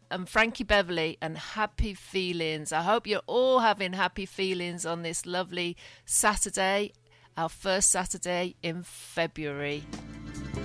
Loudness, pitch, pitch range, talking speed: -28 LUFS, 180 Hz, 160-195 Hz, 125 wpm